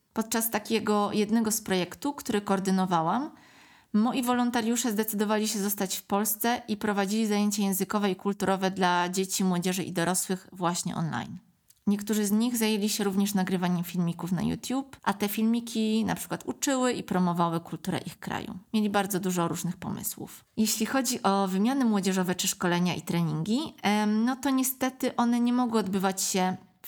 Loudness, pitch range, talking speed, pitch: -28 LUFS, 185-225 Hz, 155 wpm, 205 Hz